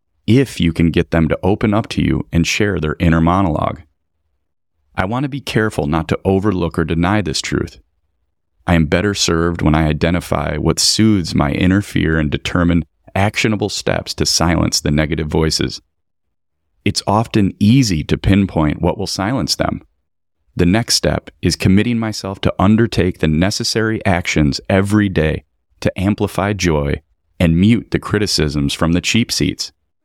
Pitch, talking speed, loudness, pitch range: 85 Hz, 160 wpm, -16 LUFS, 80-105 Hz